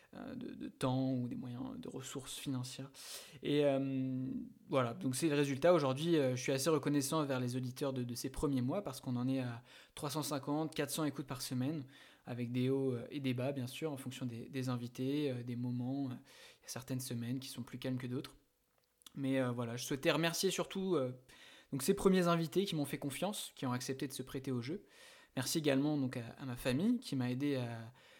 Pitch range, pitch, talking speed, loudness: 125-150 Hz, 135 Hz, 210 wpm, -38 LUFS